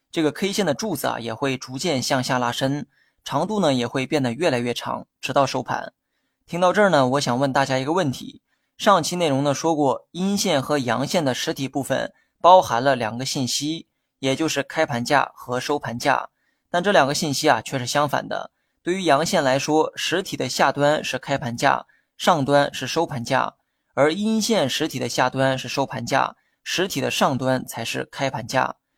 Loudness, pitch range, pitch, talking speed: -22 LUFS, 130-160 Hz, 140 Hz, 275 characters per minute